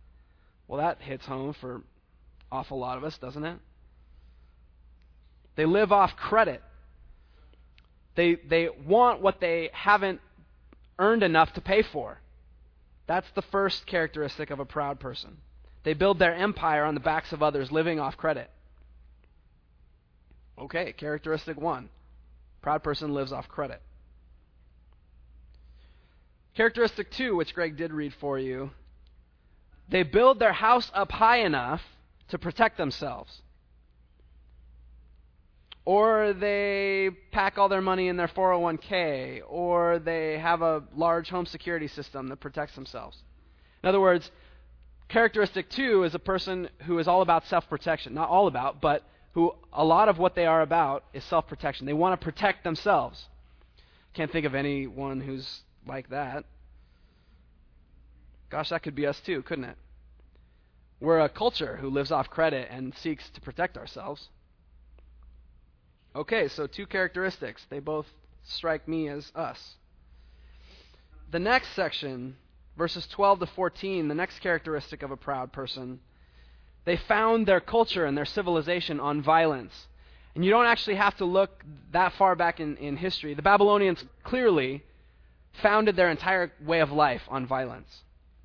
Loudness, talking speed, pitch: -27 LUFS, 140 wpm, 145 Hz